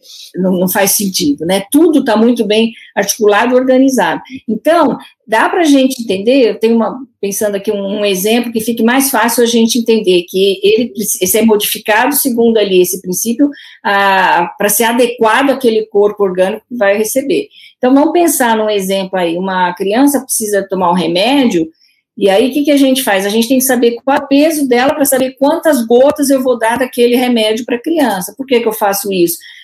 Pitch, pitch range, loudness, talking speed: 230 Hz, 200-265 Hz, -11 LUFS, 200 wpm